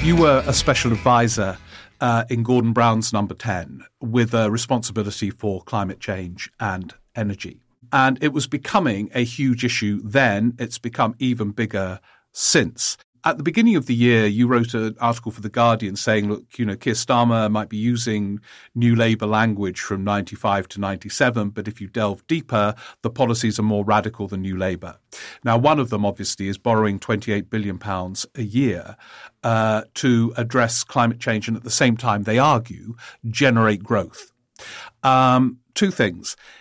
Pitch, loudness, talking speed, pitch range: 115 Hz, -21 LUFS, 170 wpm, 105-120 Hz